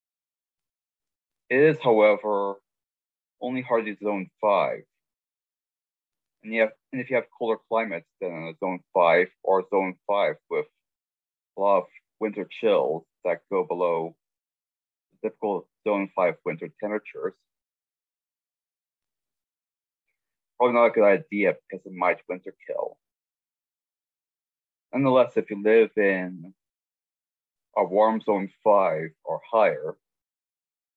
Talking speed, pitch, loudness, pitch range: 110 wpm, 105 Hz, -25 LUFS, 90-125 Hz